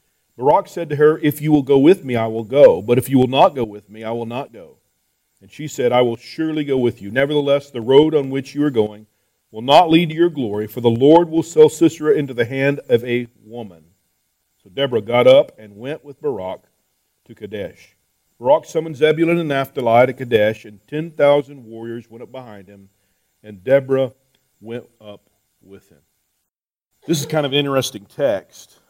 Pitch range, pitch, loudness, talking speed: 110-145 Hz, 130 Hz, -17 LUFS, 205 wpm